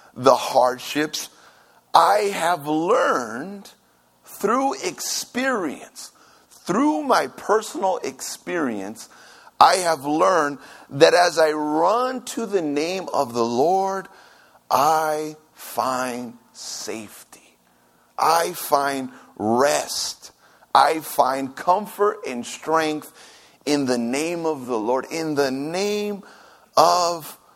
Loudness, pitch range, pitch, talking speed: -21 LUFS, 140-200 Hz, 155 Hz, 100 wpm